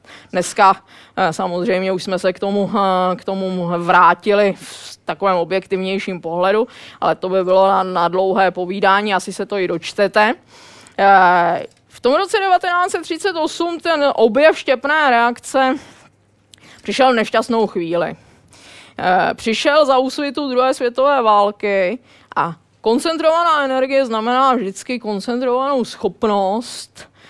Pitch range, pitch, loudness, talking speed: 190-265 Hz, 210 Hz, -16 LUFS, 110 wpm